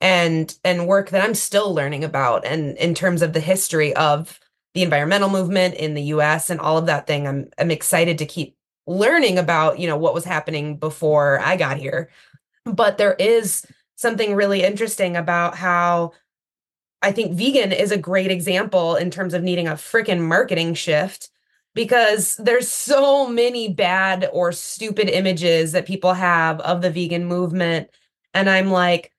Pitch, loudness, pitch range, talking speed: 180 Hz, -19 LUFS, 160-190 Hz, 170 wpm